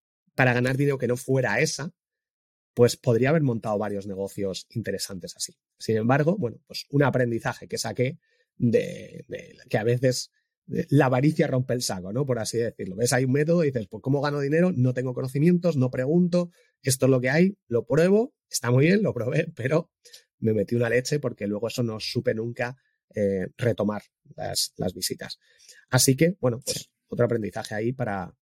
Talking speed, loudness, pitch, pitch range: 185 wpm, -25 LUFS, 130 Hz, 115-155 Hz